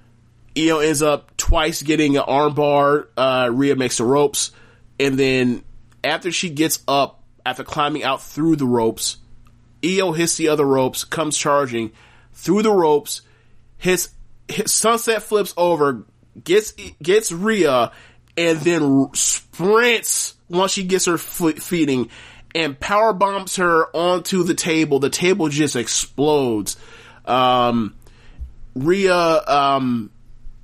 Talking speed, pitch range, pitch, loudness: 130 wpm, 120-170 Hz, 145 Hz, -18 LUFS